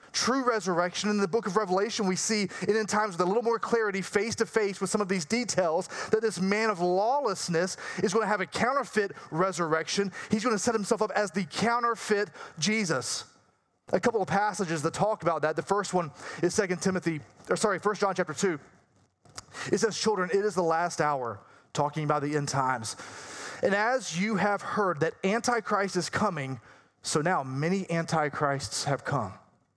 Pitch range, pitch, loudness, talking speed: 165-215 Hz, 195 Hz, -28 LUFS, 190 wpm